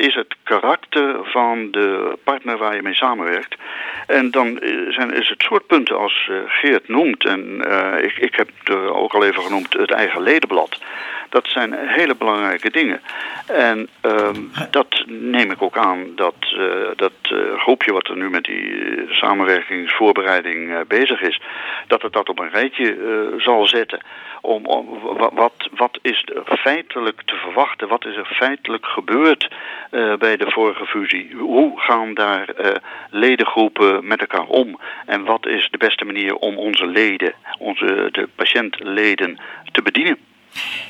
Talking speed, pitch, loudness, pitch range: 160 wpm, 115 Hz, -17 LUFS, 100-130 Hz